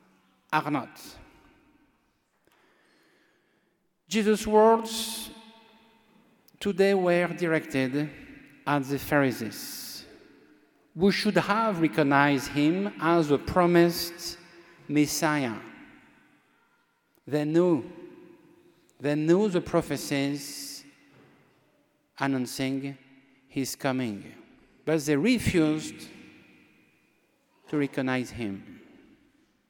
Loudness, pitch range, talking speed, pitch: -26 LUFS, 140-210 Hz, 70 wpm, 170 Hz